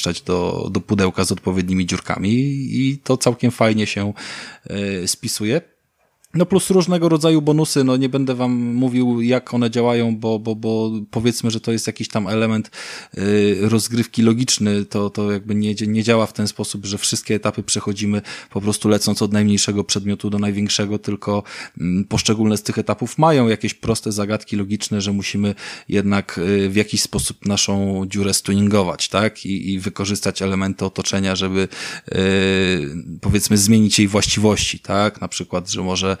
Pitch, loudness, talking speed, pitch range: 105 Hz, -19 LUFS, 155 wpm, 100-115 Hz